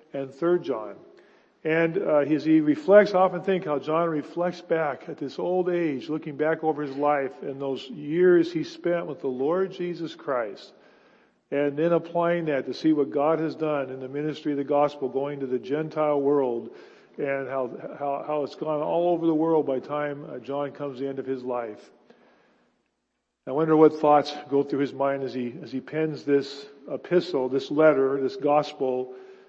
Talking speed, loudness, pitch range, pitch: 195 wpm, -25 LUFS, 140-160 Hz, 150 Hz